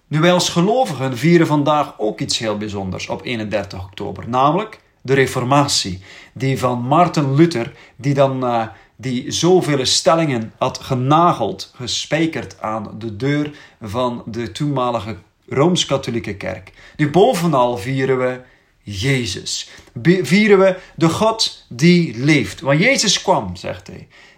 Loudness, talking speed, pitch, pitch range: -17 LUFS, 135 wpm, 130 Hz, 115-155 Hz